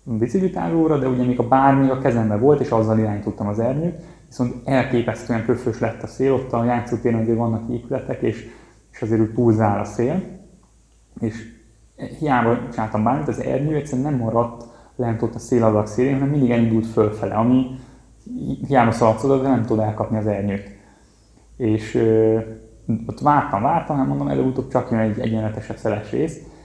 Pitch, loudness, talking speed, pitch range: 115 Hz, -20 LUFS, 170 wpm, 110-130 Hz